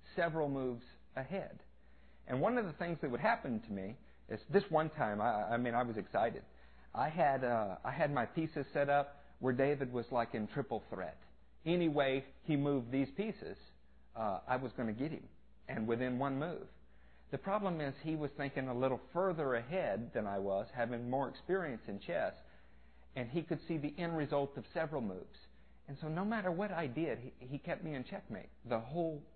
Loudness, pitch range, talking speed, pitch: -38 LUFS, 115-160 Hz, 200 wpm, 135 Hz